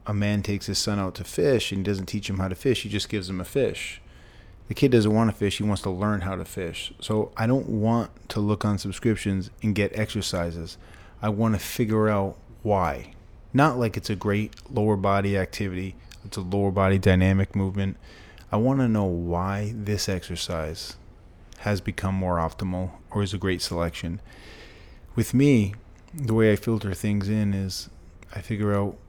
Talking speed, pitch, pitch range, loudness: 195 wpm, 100 Hz, 95-105 Hz, -25 LUFS